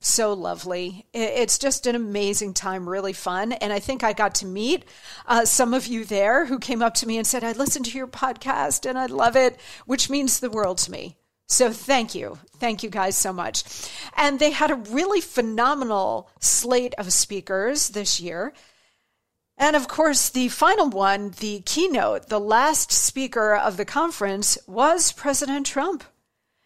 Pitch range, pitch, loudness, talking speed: 205-275 Hz, 240 Hz, -22 LUFS, 180 wpm